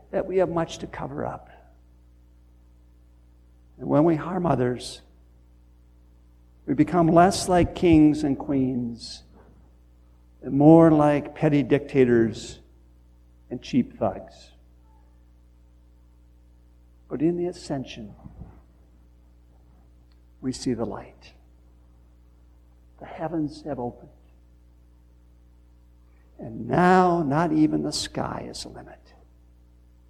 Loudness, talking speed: -23 LUFS, 95 wpm